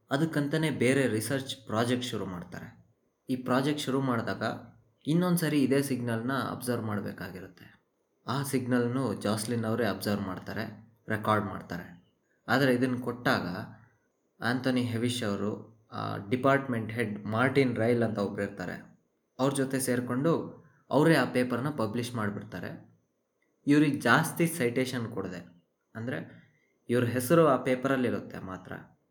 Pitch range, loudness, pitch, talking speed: 110-135 Hz, -29 LUFS, 120 Hz, 115 wpm